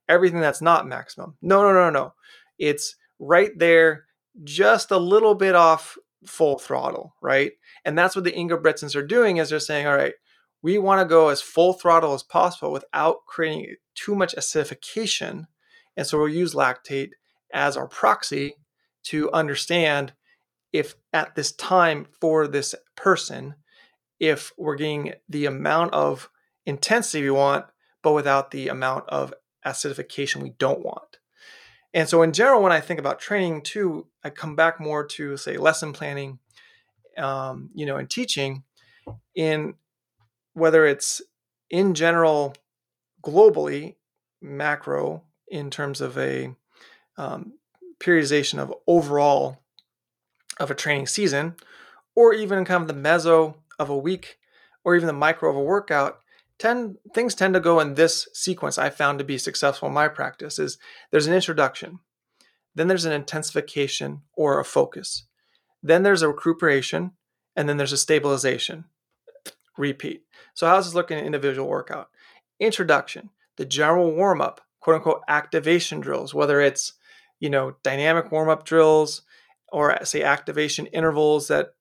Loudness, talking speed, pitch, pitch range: -22 LUFS, 150 wpm, 160 Hz, 145-185 Hz